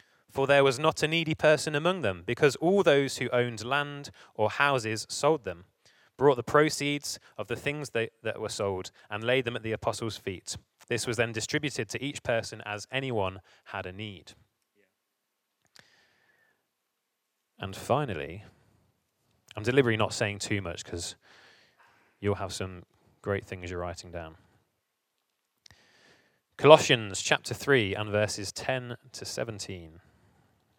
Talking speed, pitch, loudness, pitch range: 140 wpm, 115 Hz, -28 LUFS, 100-135 Hz